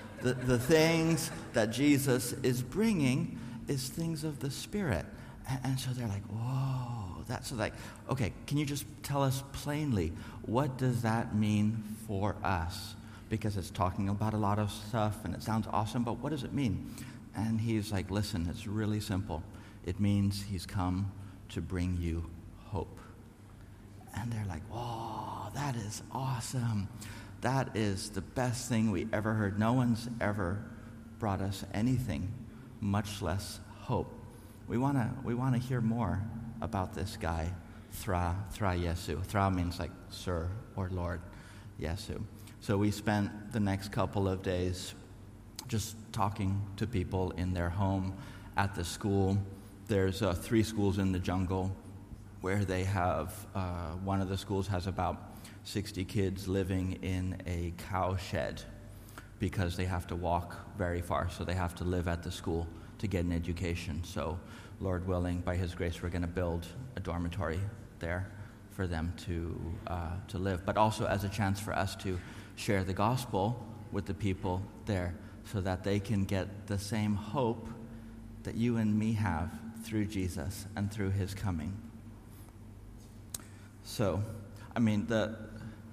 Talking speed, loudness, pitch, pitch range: 160 wpm, -35 LUFS, 105 Hz, 95-110 Hz